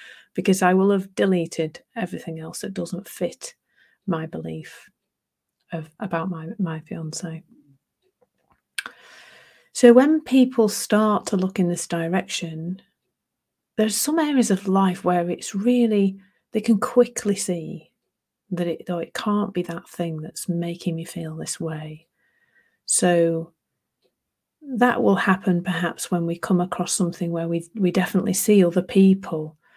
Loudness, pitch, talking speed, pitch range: -22 LUFS, 180 Hz, 135 wpm, 170-210 Hz